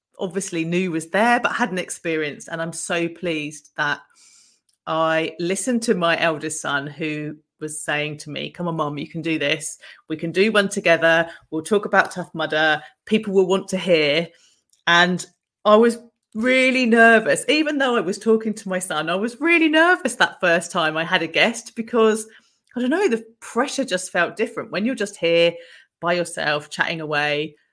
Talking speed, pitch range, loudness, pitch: 190 wpm, 160-220 Hz, -20 LUFS, 175 Hz